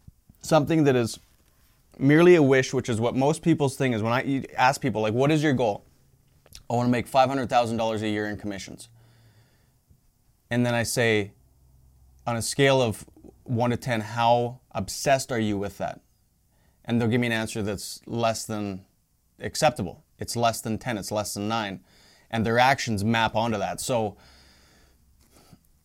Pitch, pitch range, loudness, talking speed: 115 Hz, 105-125 Hz, -24 LUFS, 175 wpm